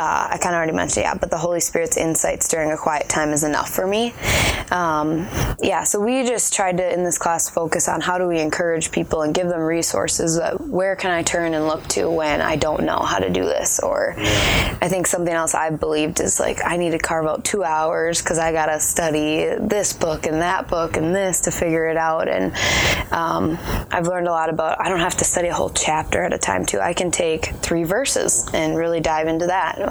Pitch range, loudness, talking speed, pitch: 160-180 Hz, -19 LUFS, 240 wpm, 165 Hz